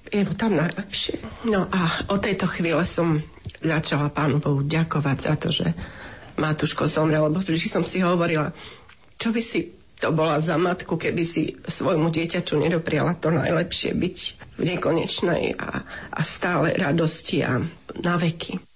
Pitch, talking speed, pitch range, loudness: 165 Hz, 155 wpm, 150-175 Hz, -24 LUFS